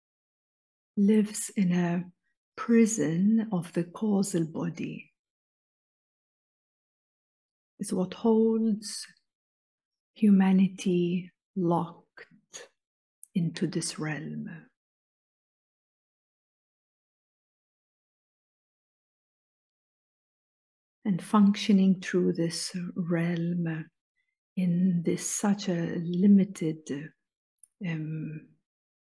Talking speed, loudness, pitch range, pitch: 55 wpm, -27 LUFS, 170-205 Hz, 185 Hz